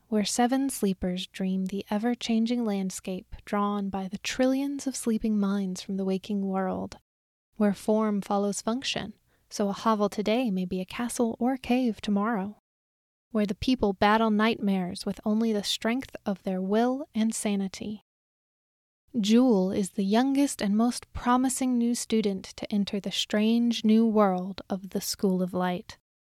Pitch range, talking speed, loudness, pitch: 200-235 Hz, 155 wpm, -27 LUFS, 210 Hz